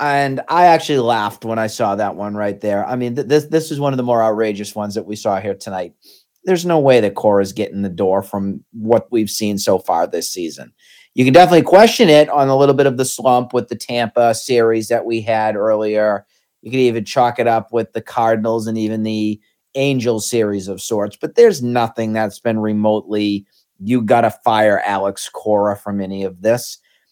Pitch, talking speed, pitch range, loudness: 115 Hz, 210 wpm, 105-125 Hz, -16 LUFS